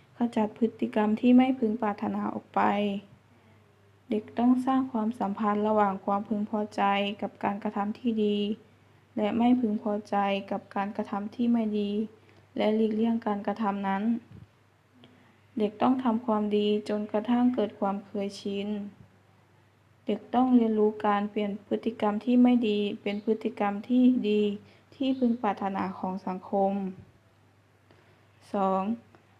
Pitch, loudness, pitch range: 205 Hz, -28 LUFS, 195-220 Hz